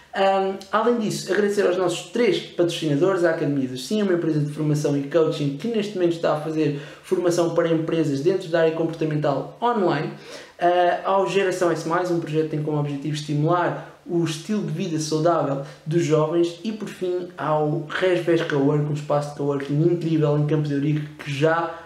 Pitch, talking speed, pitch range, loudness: 165 Hz, 185 wpm, 150-175 Hz, -22 LUFS